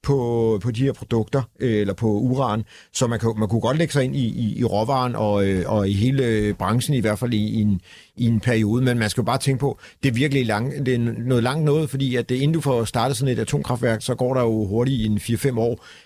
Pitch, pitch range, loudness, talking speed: 120 Hz, 110-130 Hz, -22 LUFS, 260 wpm